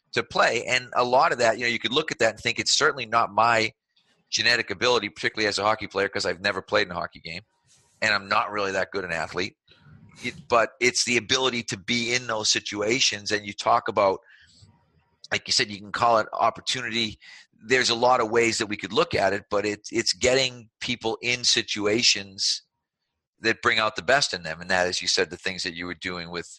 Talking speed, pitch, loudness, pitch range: 230 wpm, 110 Hz, -23 LUFS, 95-120 Hz